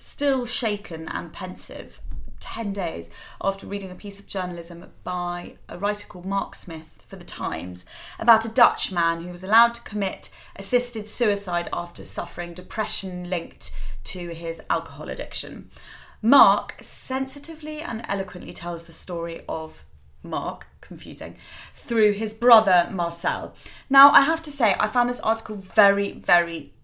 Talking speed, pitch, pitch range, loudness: 145 wpm, 195 Hz, 170-225 Hz, -24 LUFS